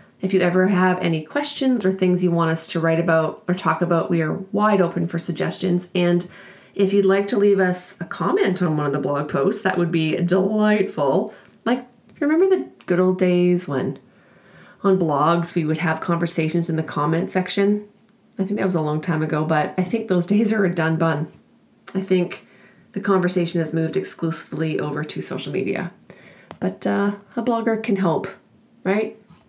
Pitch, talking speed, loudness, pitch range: 185 Hz, 190 wpm, -21 LUFS, 165-200 Hz